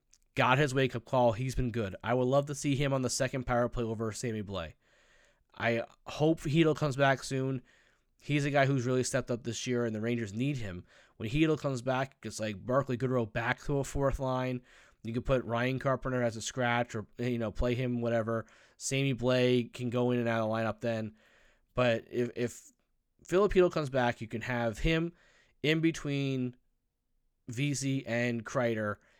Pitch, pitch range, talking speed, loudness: 125 Hz, 115-135 Hz, 195 wpm, -32 LUFS